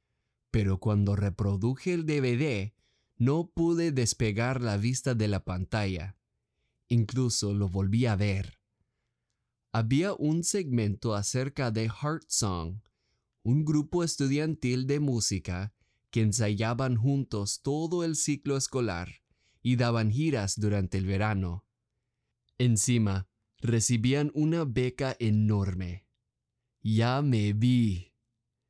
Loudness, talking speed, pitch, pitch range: -29 LUFS, 105 wpm, 115 Hz, 105-130 Hz